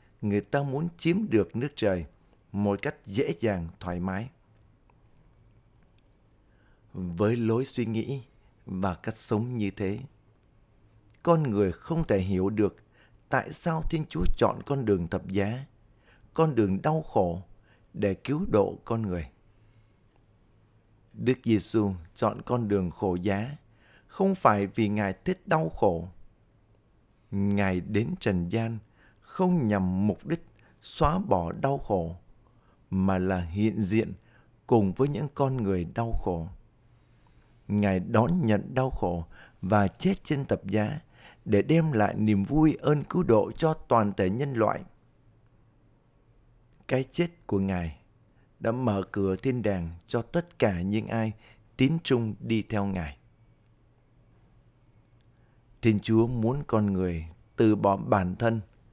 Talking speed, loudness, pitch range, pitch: 135 wpm, -28 LUFS, 100-120 Hz, 110 Hz